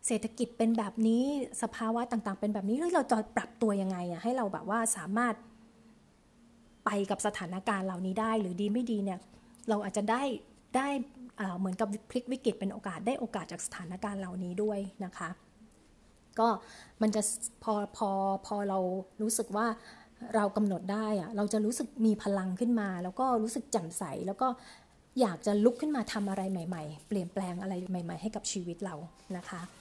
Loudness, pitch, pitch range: -33 LUFS, 215 Hz, 195-230 Hz